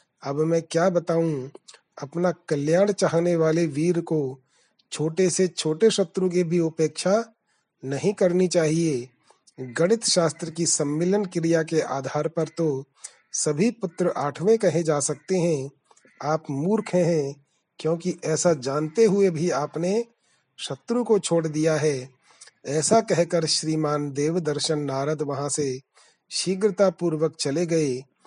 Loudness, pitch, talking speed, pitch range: -24 LUFS, 165 Hz, 130 wpm, 150-180 Hz